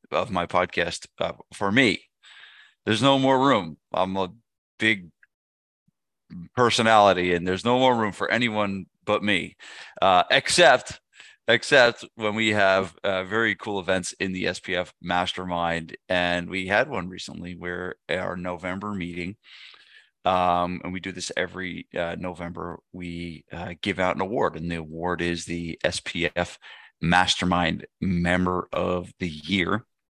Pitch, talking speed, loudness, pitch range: 90 Hz, 145 wpm, -24 LUFS, 85-105 Hz